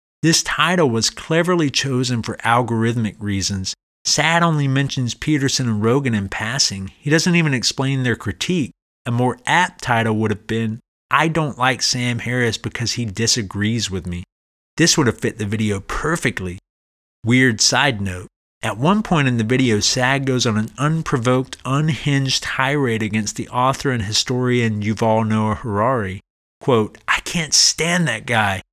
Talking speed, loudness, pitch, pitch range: 160 wpm, -18 LUFS, 120 Hz, 110-135 Hz